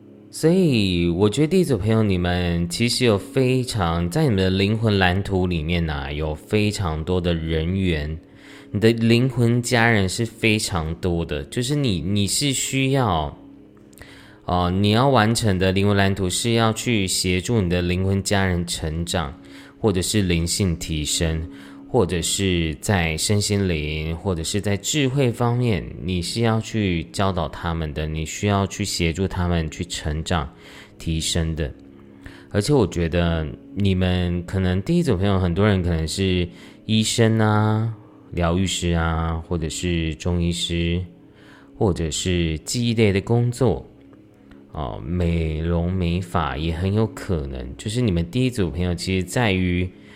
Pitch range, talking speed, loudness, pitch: 85-110 Hz, 225 characters per minute, -21 LUFS, 95 Hz